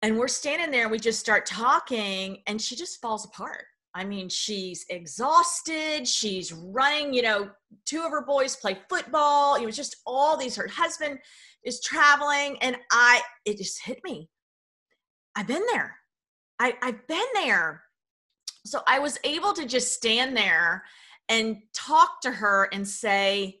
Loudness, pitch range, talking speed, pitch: -25 LUFS, 205-290 Hz, 160 wpm, 245 Hz